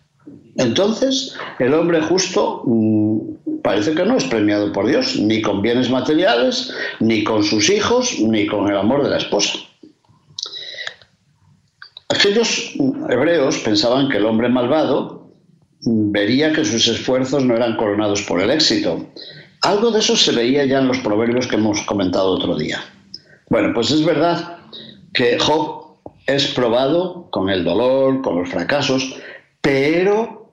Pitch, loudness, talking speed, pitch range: 135 Hz, -17 LUFS, 140 wpm, 110-185 Hz